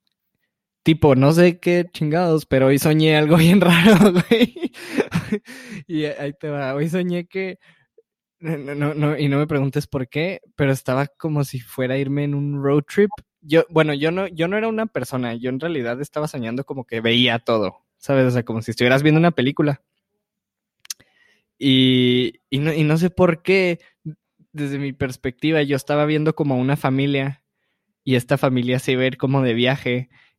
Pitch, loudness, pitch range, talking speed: 145 Hz, -19 LUFS, 135-170 Hz, 180 wpm